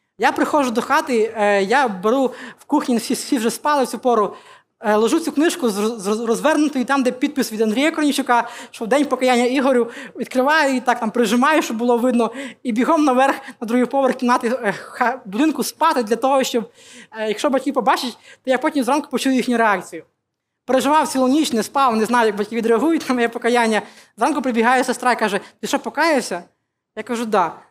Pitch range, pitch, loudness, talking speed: 230-275 Hz, 250 Hz, -18 LUFS, 185 wpm